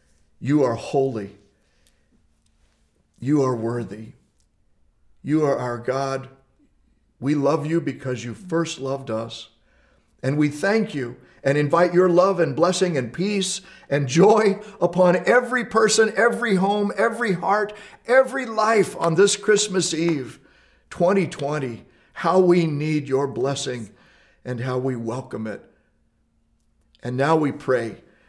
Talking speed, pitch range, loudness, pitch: 125 wpm, 125-190 Hz, -21 LUFS, 145 Hz